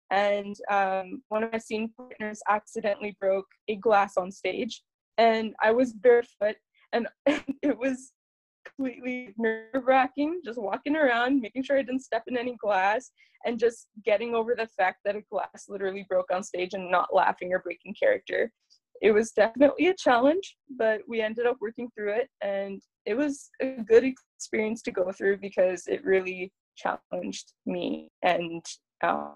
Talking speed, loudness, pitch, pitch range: 165 wpm, -27 LUFS, 220 Hz, 195-255 Hz